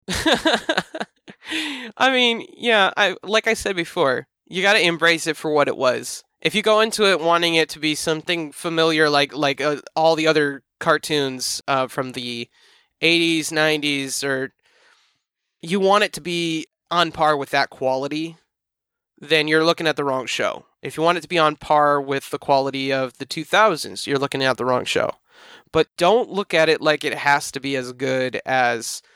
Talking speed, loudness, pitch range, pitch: 185 wpm, -20 LUFS, 140-175 Hz, 155 Hz